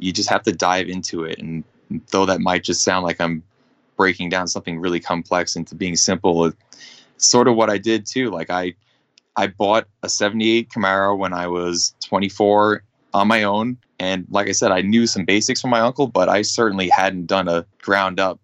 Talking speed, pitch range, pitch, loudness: 205 wpm, 90-110 Hz, 95 Hz, -19 LUFS